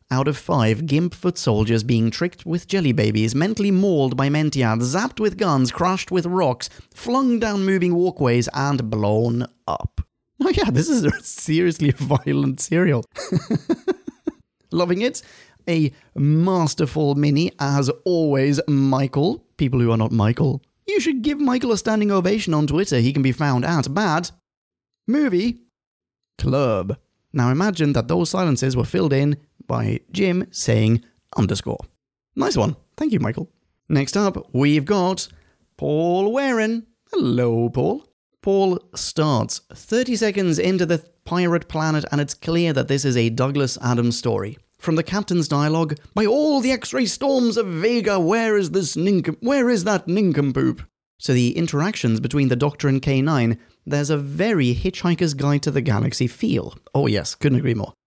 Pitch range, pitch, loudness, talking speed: 130-190 Hz, 150 Hz, -20 LUFS, 155 wpm